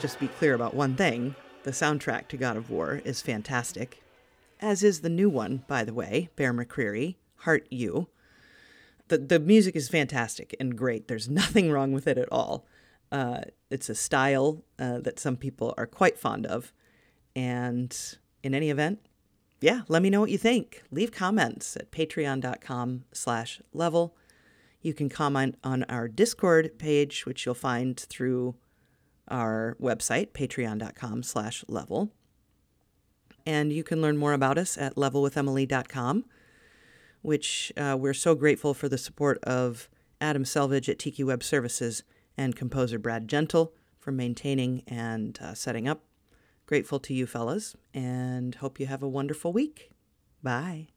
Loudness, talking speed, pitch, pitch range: -28 LUFS, 150 wpm, 135 Hz, 125-155 Hz